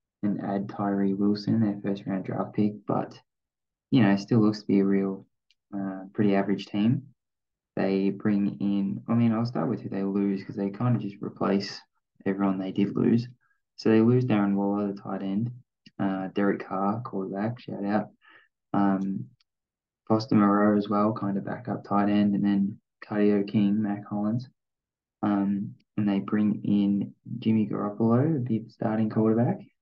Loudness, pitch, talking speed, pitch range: -27 LUFS, 100 Hz, 165 wpm, 100-110 Hz